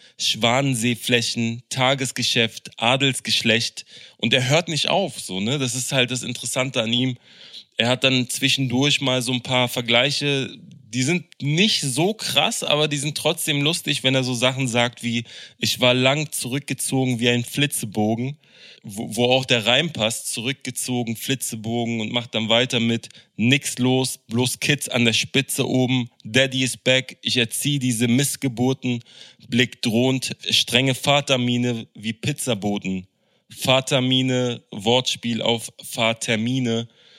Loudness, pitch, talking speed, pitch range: -21 LUFS, 125 Hz, 140 wpm, 120-135 Hz